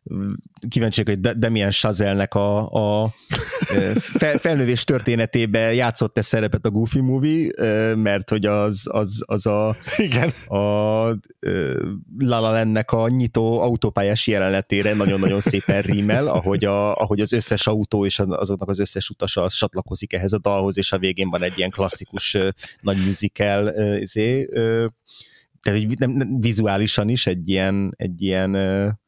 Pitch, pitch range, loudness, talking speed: 105 Hz, 100-115 Hz, -20 LUFS, 130 wpm